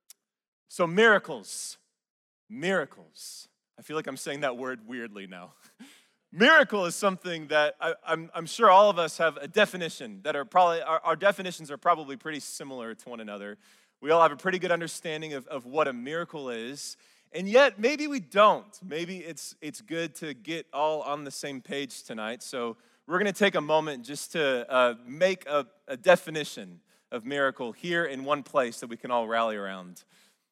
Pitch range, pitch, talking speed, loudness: 140-190 Hz, 160 Hz, 185 wpm, -27 LUFS